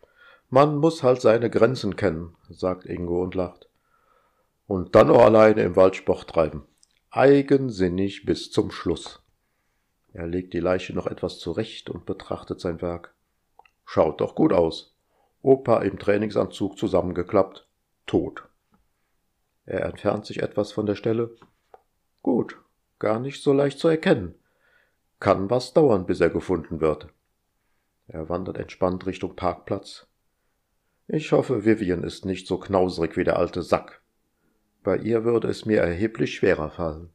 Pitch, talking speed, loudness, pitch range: 95 Hz, 140 wpm, -23 LUFS, 90-115 Hz